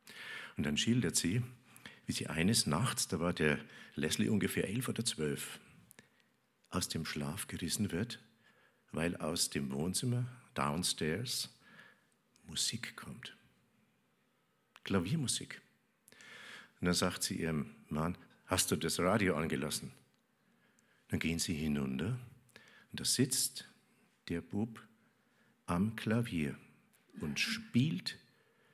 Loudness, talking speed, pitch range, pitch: -36 LUFS, 110 wpm, 80-120 Hz, 95 Hz